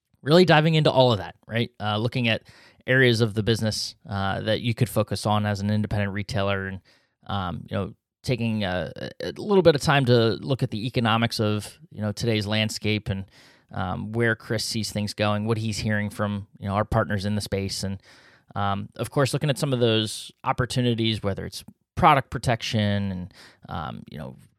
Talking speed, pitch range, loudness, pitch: 200 wpm, 105-120 Hz, -24 LUFS, 110 Hz